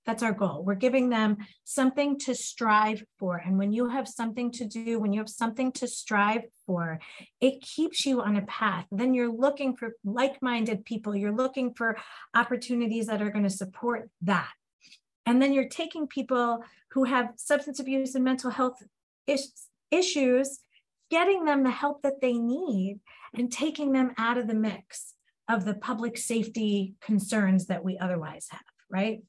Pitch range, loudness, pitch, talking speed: 210-260 Hz, -28 LUFS, 235 Hz, 175 wpm